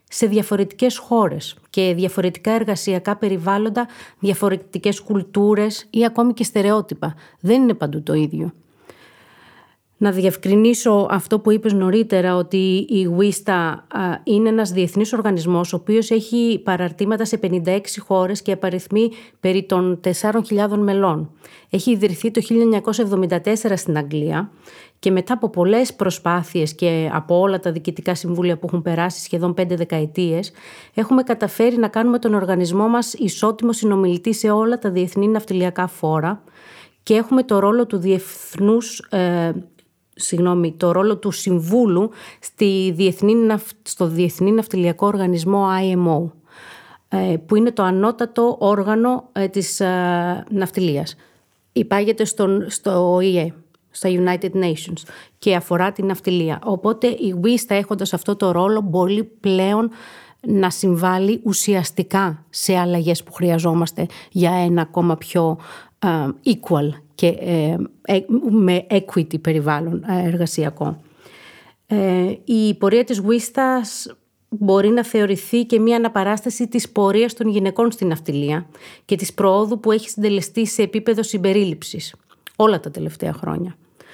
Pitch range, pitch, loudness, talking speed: 180-215 Hz, 195 Hz, -19 LUFS, 130 wpm